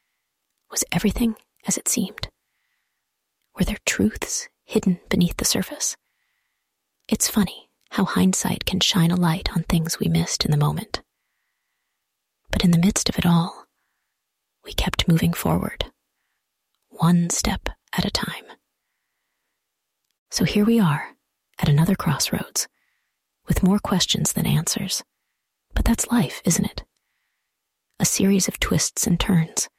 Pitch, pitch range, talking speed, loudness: 190 Hz, 170-215 Hz, 135 wpm, -22 LUFS